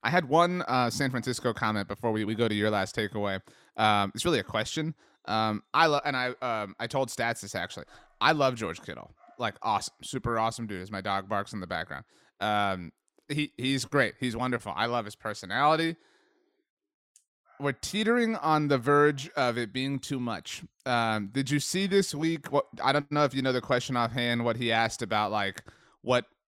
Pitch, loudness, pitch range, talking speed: 120 Hz, -29 LUFS, 110-145 Hz, 200 wpm